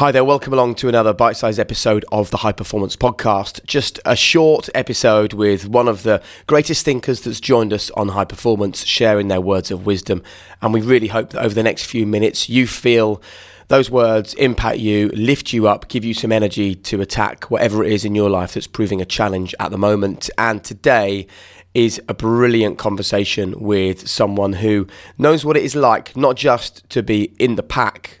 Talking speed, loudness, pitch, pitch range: 200 wpm, -17 LUFS, 110 Hz, 100-120 Hz